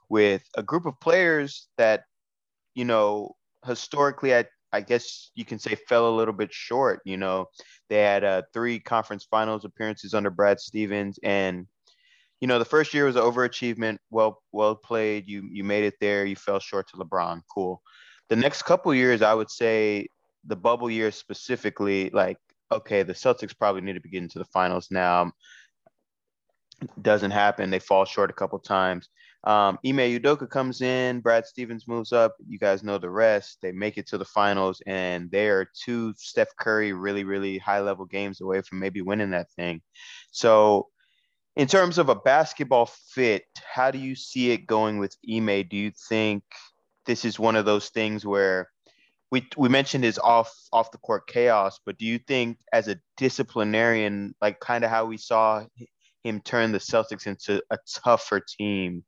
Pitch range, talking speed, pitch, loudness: 100-120 Hz, 185 wpm, 110 Hz, -25 LUFS